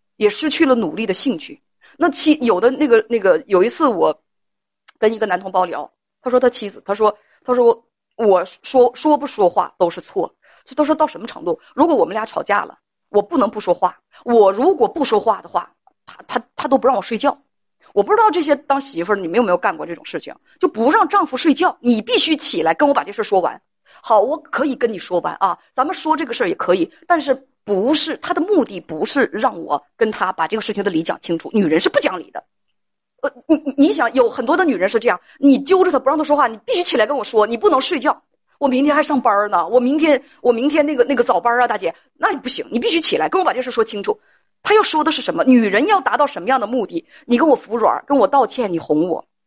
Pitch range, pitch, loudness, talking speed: 215-310 Hz, 260 Hz, -17 LUFS, 340 characters per minute